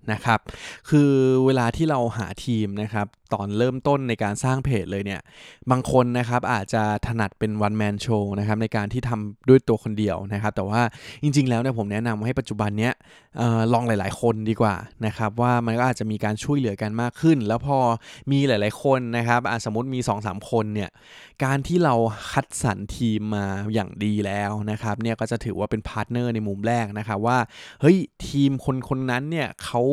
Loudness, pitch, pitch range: -23 LUFS, 115 Hz, 105-125 Hz